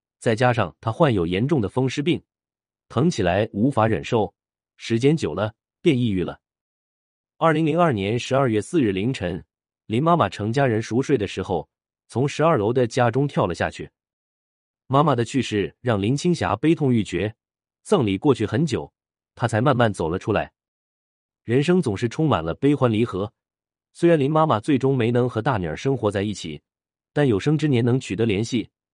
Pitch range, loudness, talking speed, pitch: 100-140 Hz, -22 LUFS, 265 characters per minute, 120 Hz